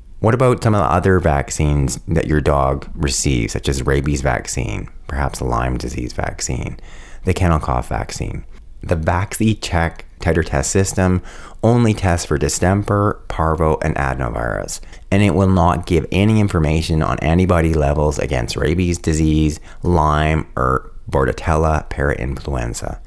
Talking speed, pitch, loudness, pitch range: 140 wpm, 80 Hz, -18 LUFS, 70-90 Hz